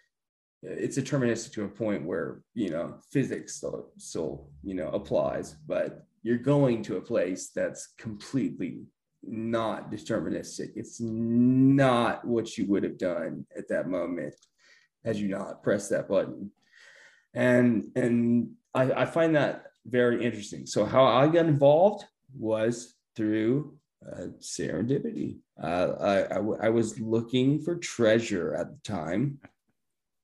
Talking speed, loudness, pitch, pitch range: 135 wpm, -28 LUFS, 120 Hz, 110-135 Hz